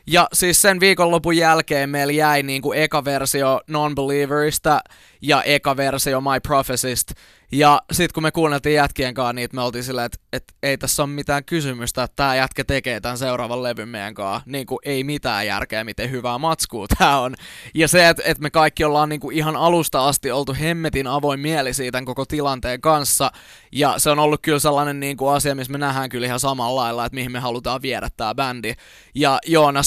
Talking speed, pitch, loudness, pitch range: 190 wpm, 140 Hz, -19 LUFS, 125-150 Hz